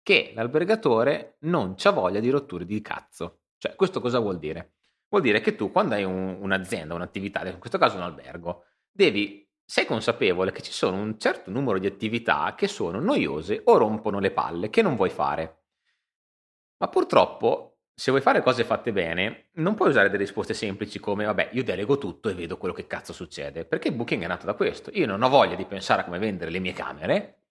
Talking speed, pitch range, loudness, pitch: 205 wpm, 85-105 Hz, -25 LUFS, 95 Hz